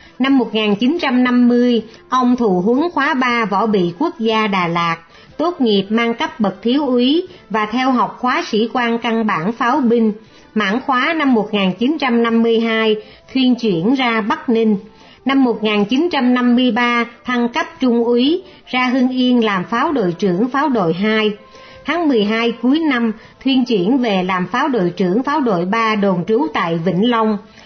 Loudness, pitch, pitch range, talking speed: -16 LUFS, 235 Hz, 215-255 Hz, 160 wpm